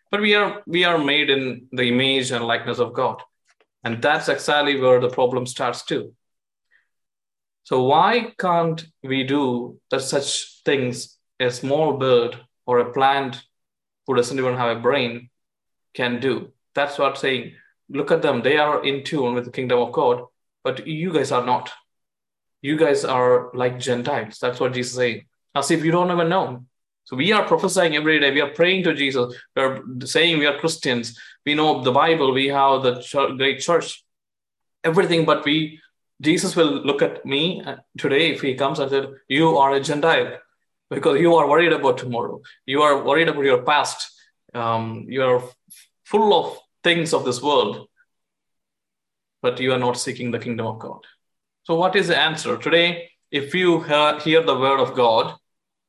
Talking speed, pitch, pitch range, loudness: 180 wpm, 140 Hz, 125-165 Hz, -20 LUFS